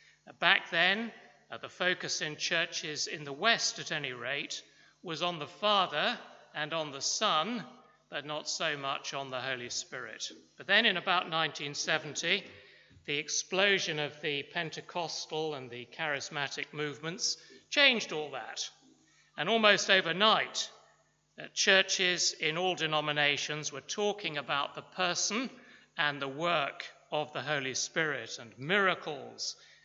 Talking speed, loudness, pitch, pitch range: 135 wpm, -31 LUFS, 160 Hz, 145-185 Hz